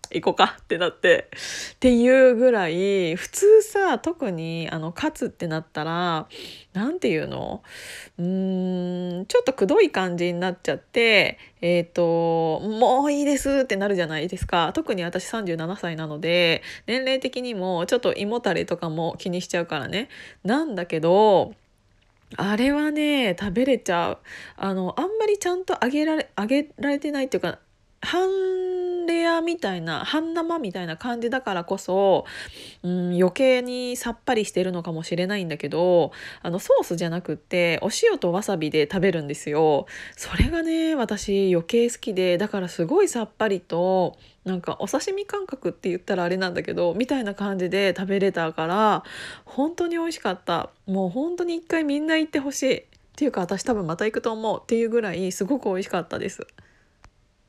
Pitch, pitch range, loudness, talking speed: 200 Hz, 175-270 Hz, -23 LUFS, 340 characters per minute